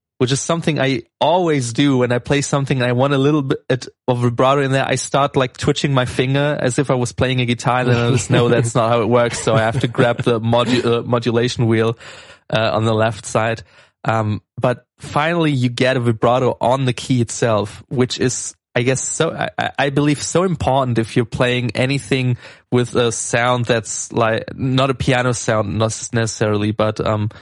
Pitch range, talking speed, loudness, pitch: 115-135 Hz, 210 wpm, -17 LUFS, 125 Hz